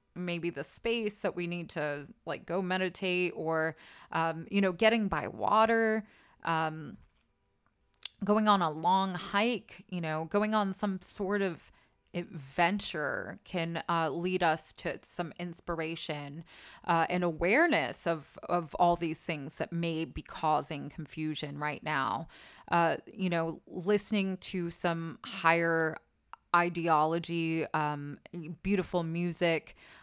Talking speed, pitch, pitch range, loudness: 130 wpm, 170 Hz, 160-190 Hz, -32 LUFS